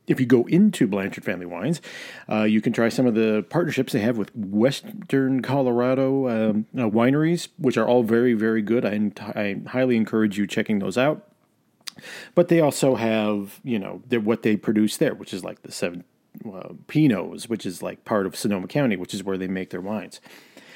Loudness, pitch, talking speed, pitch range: -23 LUFS, 115 Hz, 195 wpm, 105-130 Hz